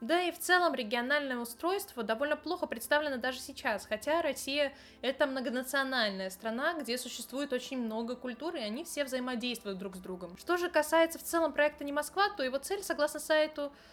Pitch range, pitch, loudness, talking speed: 245-310 Hz, 280 Hz, -33 LUFS, 175 wpm